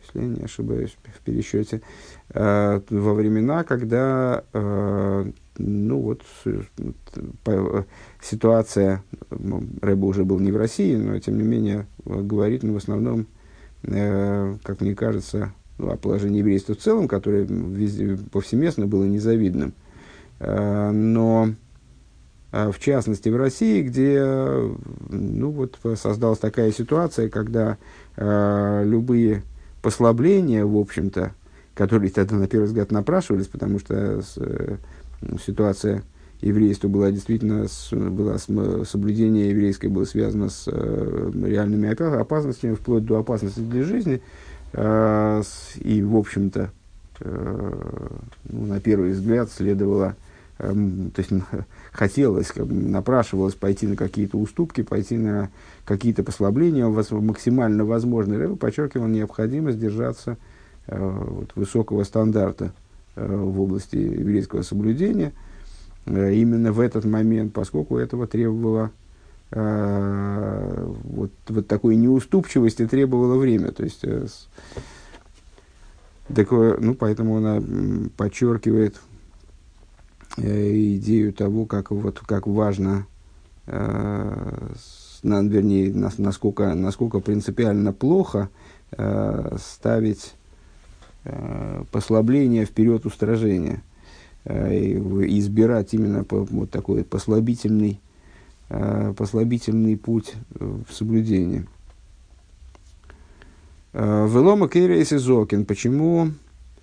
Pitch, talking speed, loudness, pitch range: 105 Hz, 95 wpm, -22 LUFS, 100-115 Hz